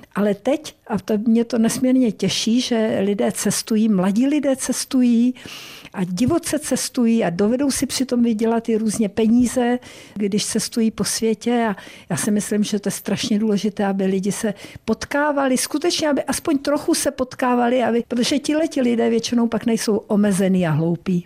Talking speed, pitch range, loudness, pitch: 165 wpm, 210-255 Hz, -20 LUFS, 230 Hz